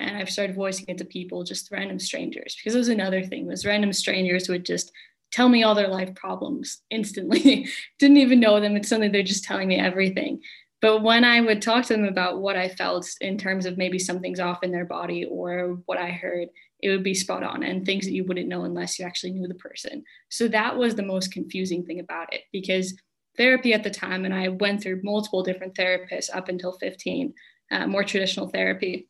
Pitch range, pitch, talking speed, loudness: 185-215 Hz, 190 Hz, 220 wpm, -24 LUFS